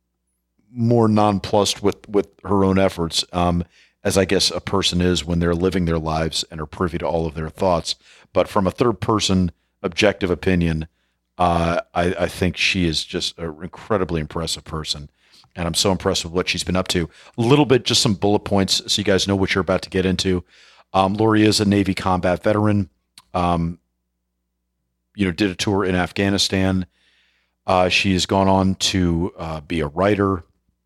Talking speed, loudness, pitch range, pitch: 190 wpm, -20 LUFS, 85-100 Hz, 90 Hz